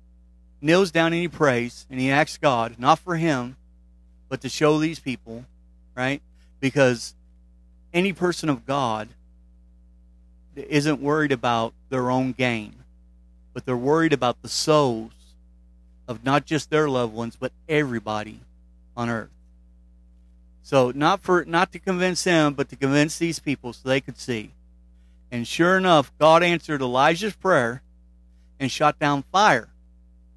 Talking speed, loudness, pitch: 140 wpm, -22 LUFS, 125 Hz